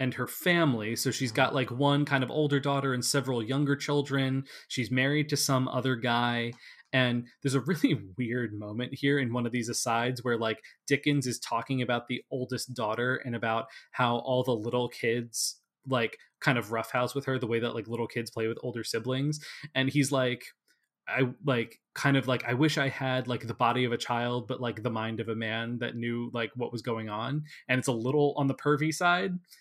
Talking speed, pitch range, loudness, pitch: 215 wpm, 120-140 Hz, -30 LUFS, 125 Hz